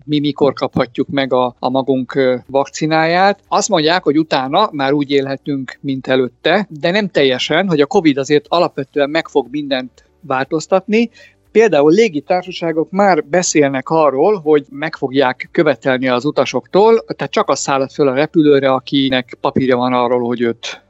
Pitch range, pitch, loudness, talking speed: 135-165 Hz, 145 Hz, -15 LUFS, 150 wpm